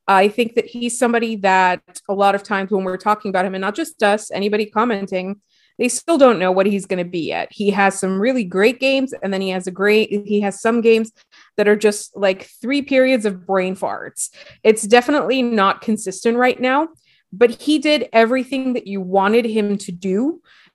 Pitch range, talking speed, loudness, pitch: 195-245 Hz, 210 wpm, -18 LUFS, 215 Hz